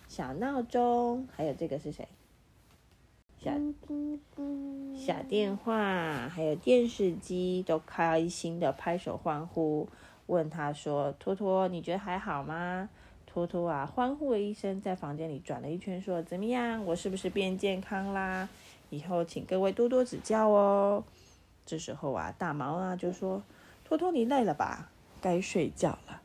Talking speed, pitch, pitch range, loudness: 215 characters per minute, 185 Hz, 160-215 Hz, -32 LUFS